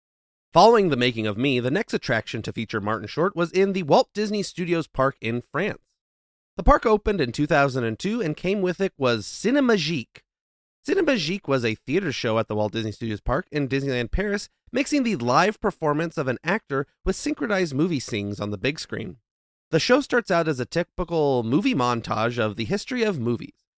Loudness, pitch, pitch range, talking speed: -24 LUFS, 150 Hz, 120-195 Hz, 190 wpm